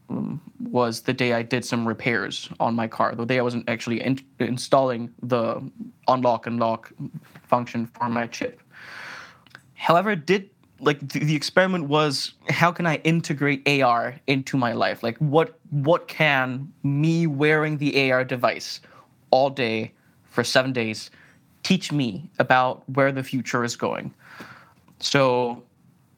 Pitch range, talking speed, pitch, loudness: 120-155 Hz, 145 wpm, 130 Hz, -23 LUFS